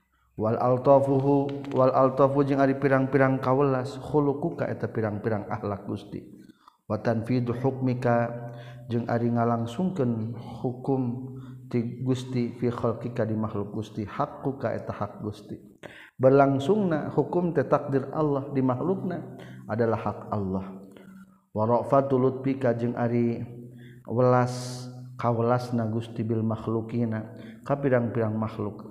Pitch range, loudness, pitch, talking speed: 115-135 Hz, -26 LUFS, 120 Hz, 100 wpm